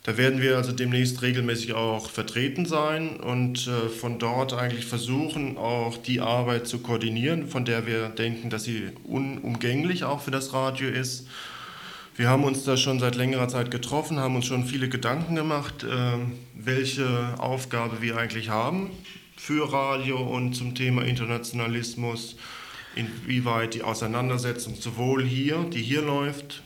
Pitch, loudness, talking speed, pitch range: 125 Hz, -27 LUFS, 150 wpm, 120-135 Hz